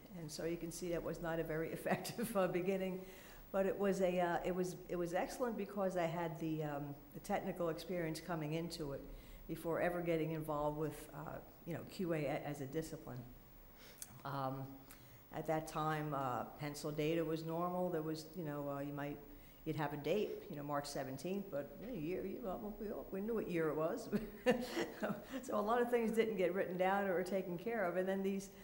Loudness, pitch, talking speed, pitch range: -41 LUFS, 165 Hz, 195 wpm, 150-190 Hz